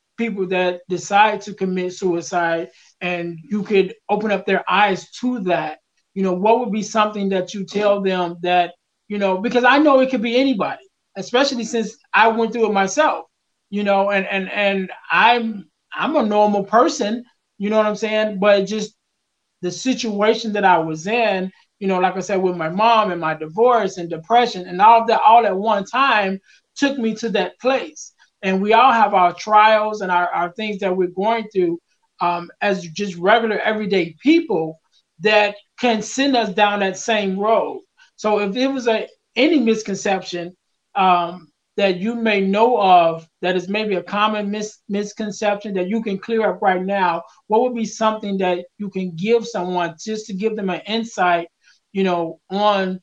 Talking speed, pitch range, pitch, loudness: 185 wpm, 185-225 Hz, 205 Hz, -18 LUFS